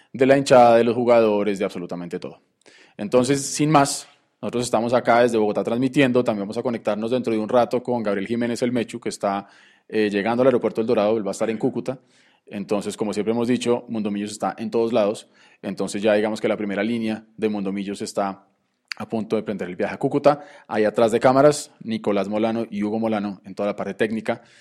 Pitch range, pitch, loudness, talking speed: 105-125 Hz, 110 Hz, -21 LUFS, 210 wpm